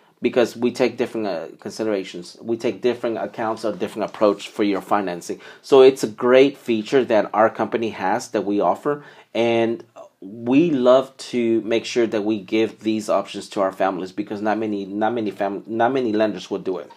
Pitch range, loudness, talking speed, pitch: 105-120 Hz, -21 LUFS, 190 wpm, 115 Hz